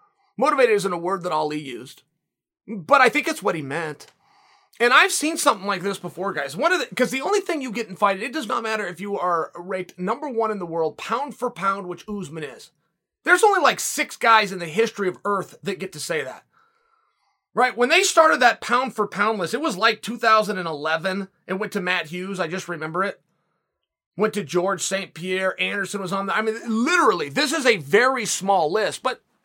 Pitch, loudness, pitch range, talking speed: 205 Hz, -22 LUFS, 185-250 Hz, 220 wpm